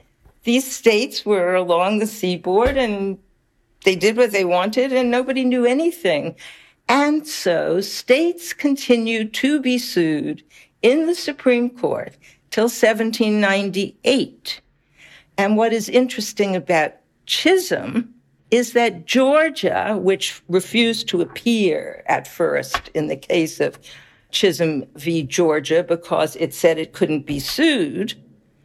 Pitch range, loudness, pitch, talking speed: 180-250 Hz, -19 LUFS, 215 Hz, 120 wpm